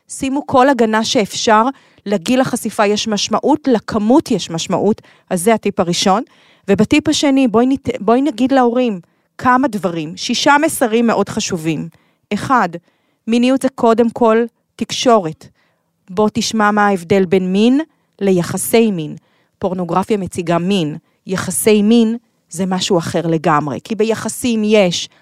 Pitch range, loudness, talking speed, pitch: 185-240 Hz, -15 LUFS, 130 wpm, 215 Hz